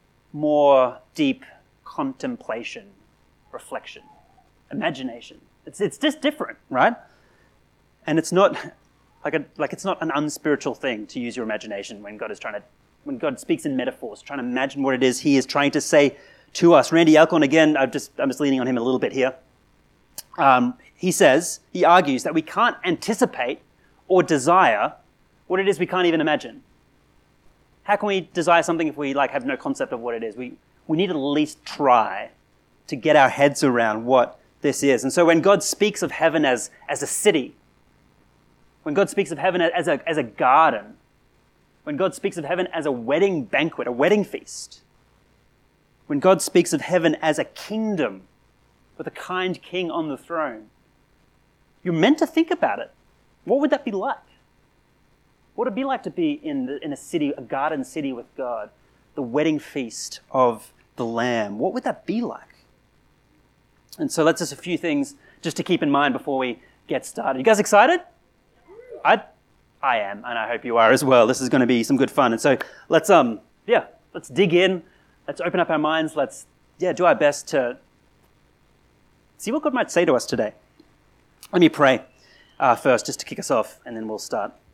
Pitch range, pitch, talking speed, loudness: 140-210 Hz, 170 Hz, 195 wpm, -21 LUFS